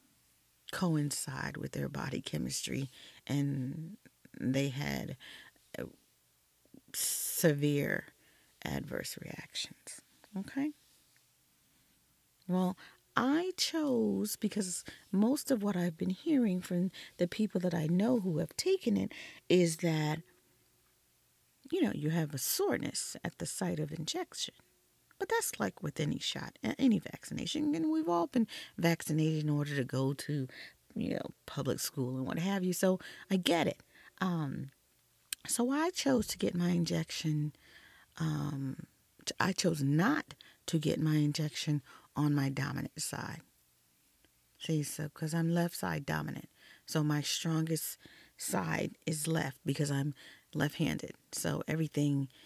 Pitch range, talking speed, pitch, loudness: 145-190 Hz, 130 wpm, 160 Hz, -34 LUFS